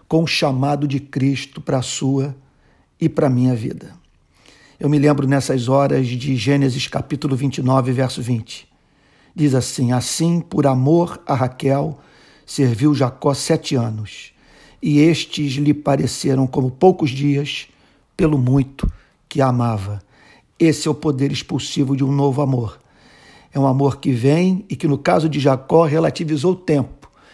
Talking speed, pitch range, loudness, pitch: 155 wpm, 130-150 Hz, -18 LUFS, 140 Hz